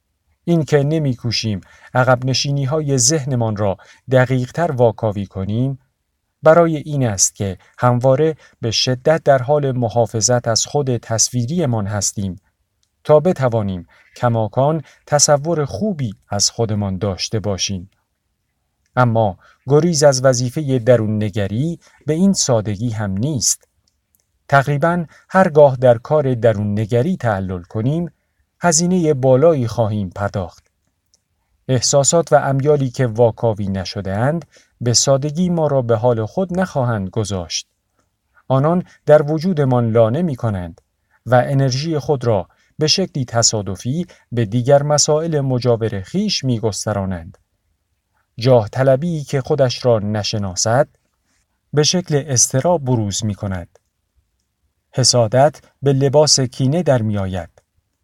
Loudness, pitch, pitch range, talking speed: -17 LUFS, 125 Hz, 105-145 Hz, 115 wpm